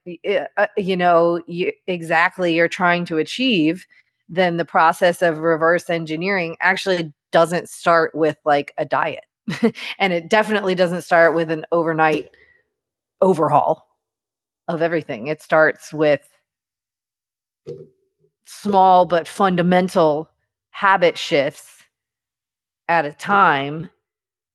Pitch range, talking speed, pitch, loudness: 160-185 Hz, 105 wpm, 170 Hz, -18 LUFS